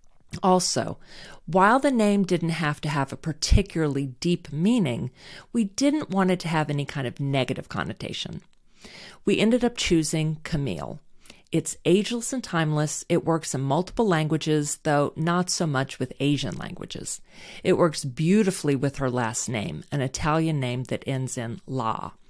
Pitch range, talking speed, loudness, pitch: 140-185 Hz, 155 wpm, -25 LUFS, 160 Hz